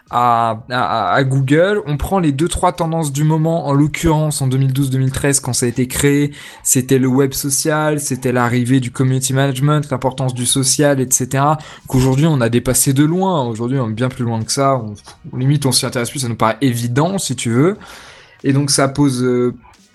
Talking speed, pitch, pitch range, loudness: 200 wpm, 135 Hz, 125-150 Hz, -15 LUFS